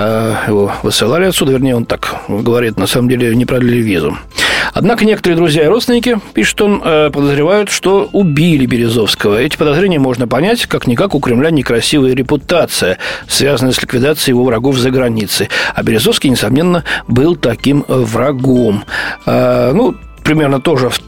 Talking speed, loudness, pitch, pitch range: 140 wpm, -11 LUFS, 130 Hz, 120-165 Hz